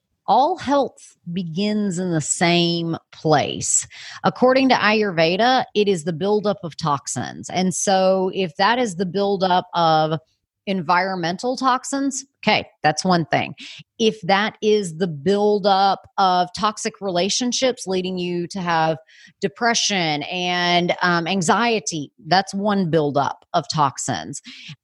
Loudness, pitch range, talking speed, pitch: -20 LUFS, 170-210 Hz, 125 wpm, 190 Hz